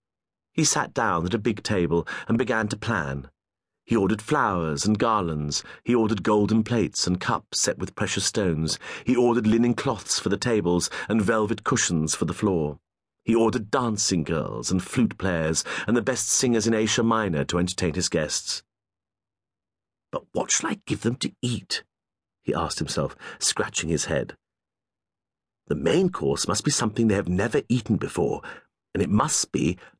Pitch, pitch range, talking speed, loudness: 105 Hz, 90-115 Hz, 170 wpm, -24 LUFS